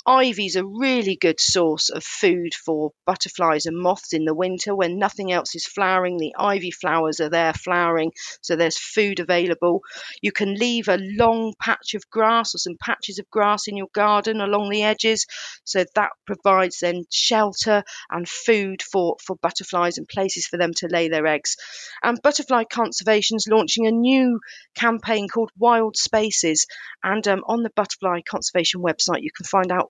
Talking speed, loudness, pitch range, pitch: 180 wpm, -21 LUFS, 175-220 Hz, 195 Hz